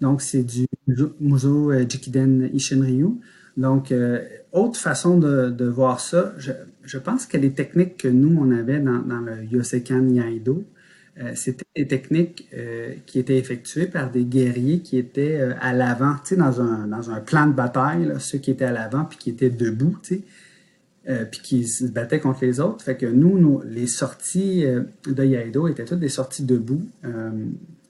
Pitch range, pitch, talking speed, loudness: 125-150 Hz, 130 Hz, 185 wpm, -21 LUFS